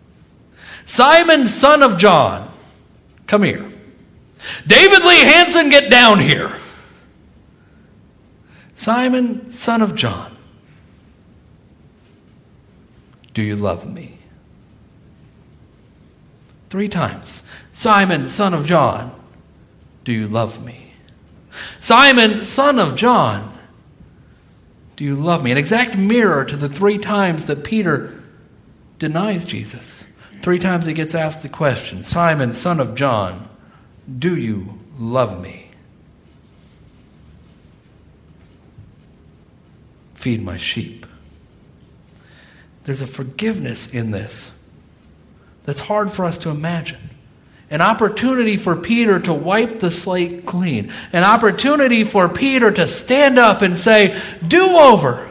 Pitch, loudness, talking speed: 175 Hz, -14 LUFS, 105 wpm